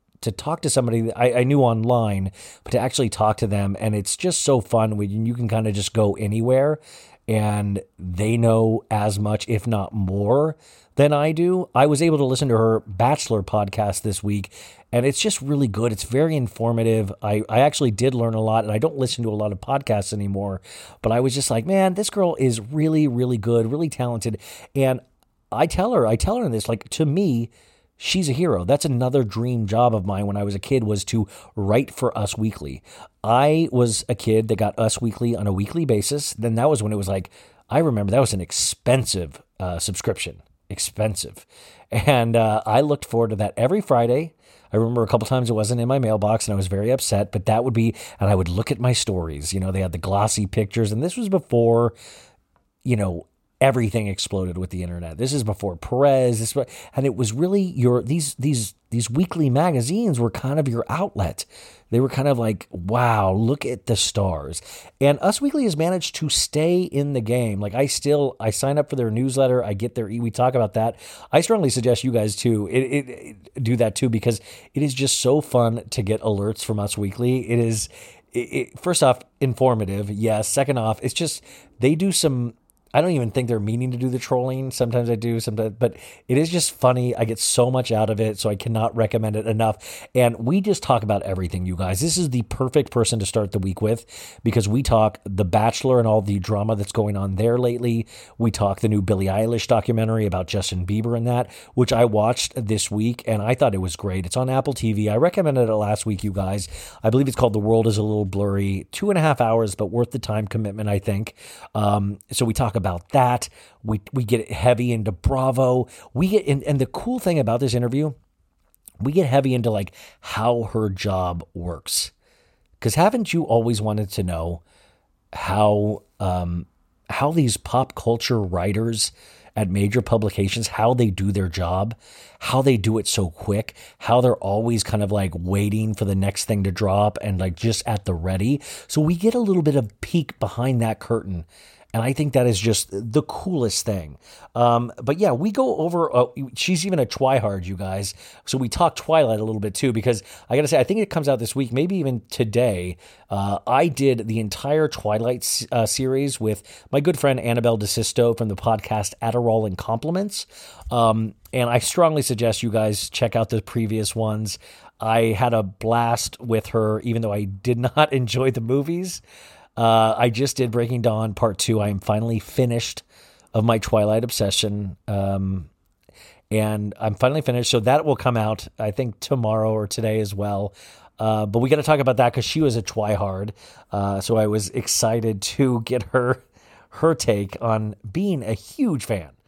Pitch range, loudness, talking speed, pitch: 105-130 Hz, -21 LUFS, 210 wpm, 115 Hz